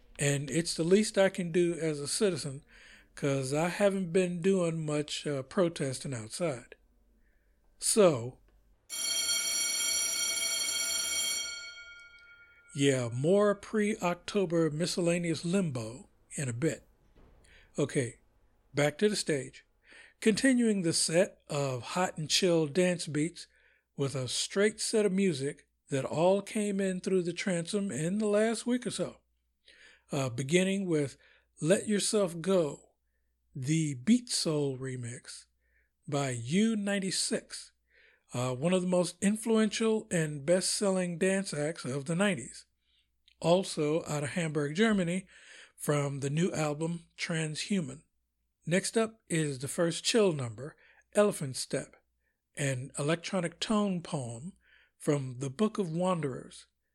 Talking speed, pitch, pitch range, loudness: 120 wpm, 170 Hz, 140-195 Hz, -31 LUFS